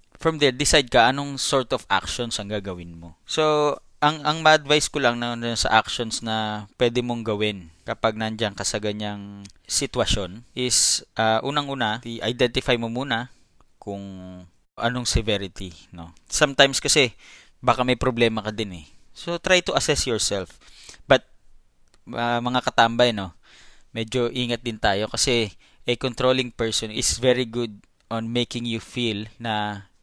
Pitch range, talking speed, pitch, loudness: 105-125 Hz, 150 wpm, 115 Hz, -22 LUFS